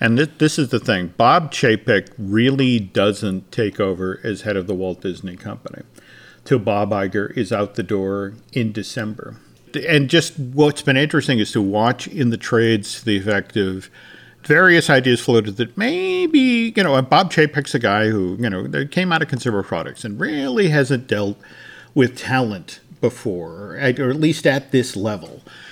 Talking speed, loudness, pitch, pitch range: 175 wpm, -18 LUFS, 120 Hz, 100-145 Hz